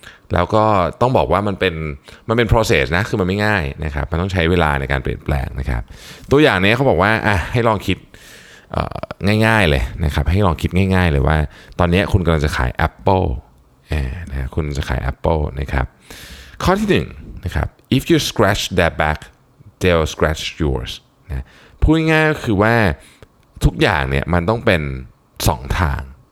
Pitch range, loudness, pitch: 70-105 Hz, -17 LUFS, 90 Hz